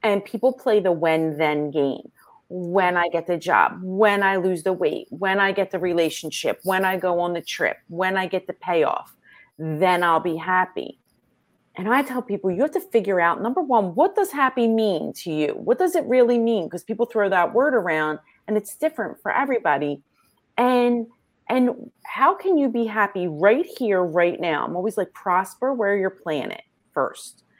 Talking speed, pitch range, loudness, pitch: 195 wpm, 175-240 Hz, -22 LUFS, 195 Hz